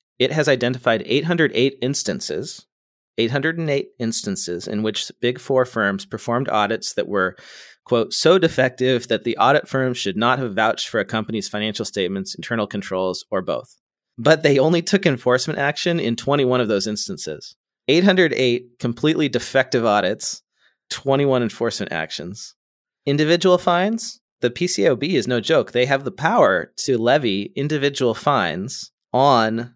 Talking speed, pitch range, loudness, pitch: 140 wpm, 115-150 Hz, -20 LUFS, 125 Hz